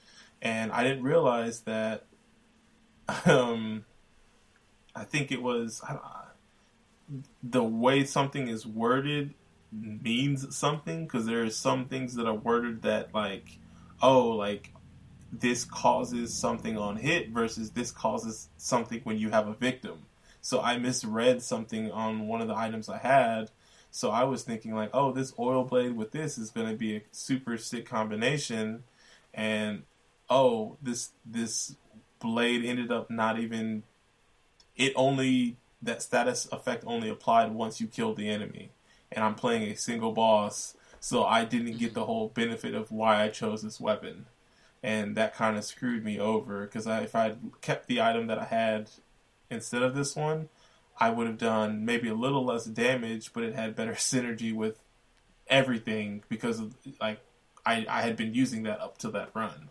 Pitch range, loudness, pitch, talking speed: 110-130 Hz, -30 LUFS, 115 Hz, 165 wpm